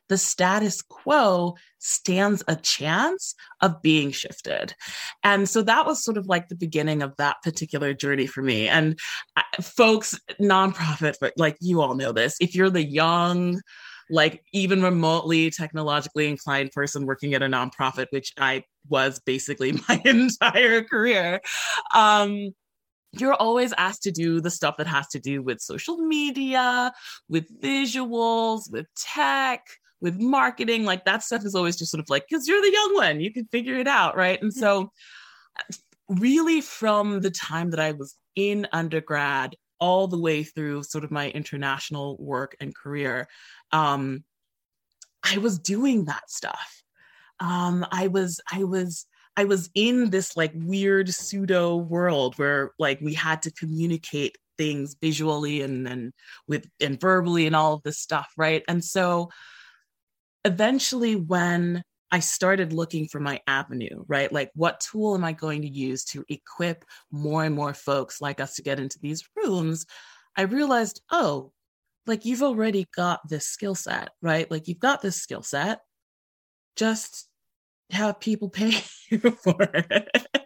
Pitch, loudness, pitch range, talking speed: 175 Hz, -24 LUFS, 150-210 Hz, 160 wpm